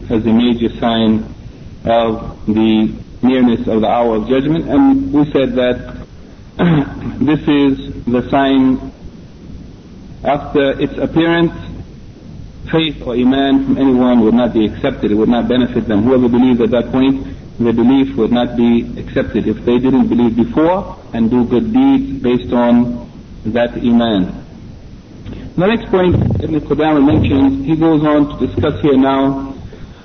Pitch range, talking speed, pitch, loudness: 115-140 Hz, 150 wpm, 125 Hz, -14 LUFS